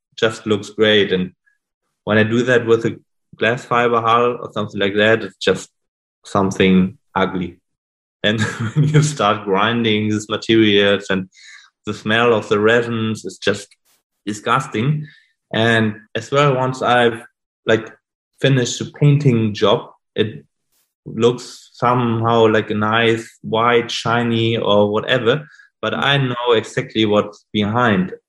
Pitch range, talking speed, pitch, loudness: 105-120 Hz, 130 wpm, 115 Hz, -17 LUFS